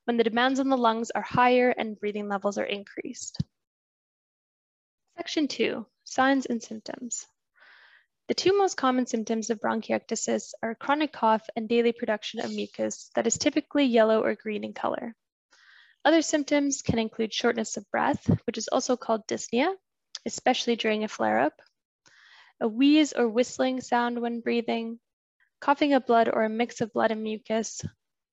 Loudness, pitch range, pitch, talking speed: -27 LUFS, 225-270 Hz, 235 Hz, 160 wpm